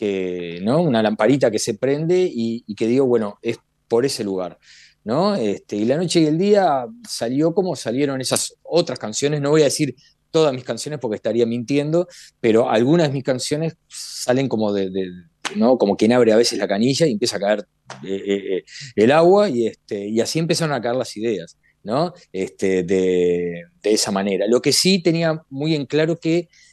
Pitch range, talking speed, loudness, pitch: 105-160 Hz, 200 wpm, -19 LUFS, 130 Hz